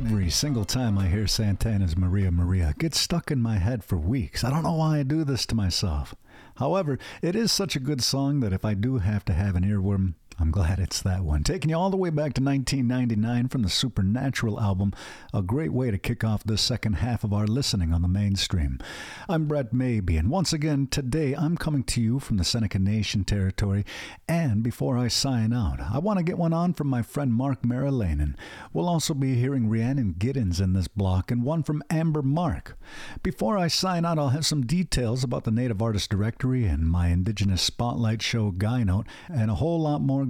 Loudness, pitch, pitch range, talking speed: -26 LUFS, 120 Hz, 100-140 Hz, 215 wpm